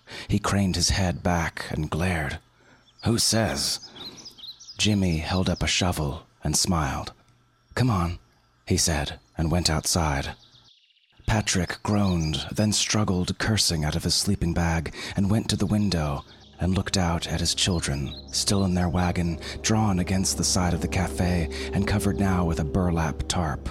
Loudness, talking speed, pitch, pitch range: -25 LUFS, 155 wpm, 90 Hz, 80-100 Hz